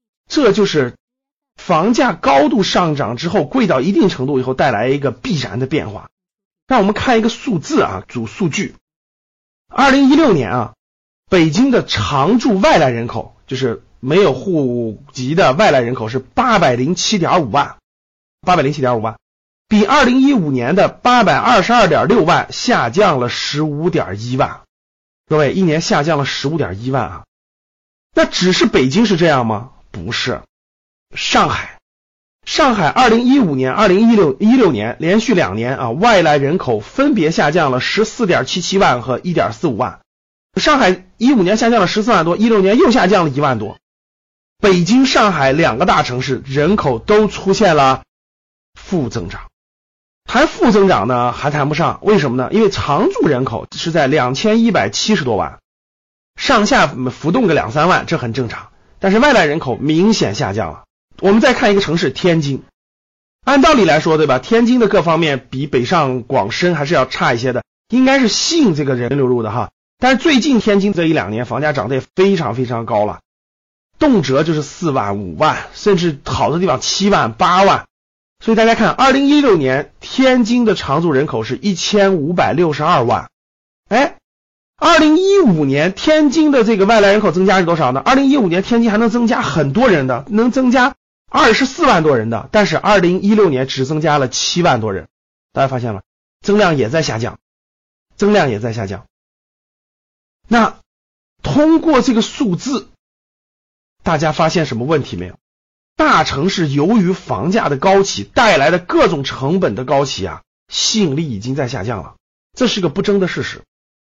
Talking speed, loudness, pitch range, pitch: 265 characters per minute, -14 LUFS, 130-220 Hz, 175 Hz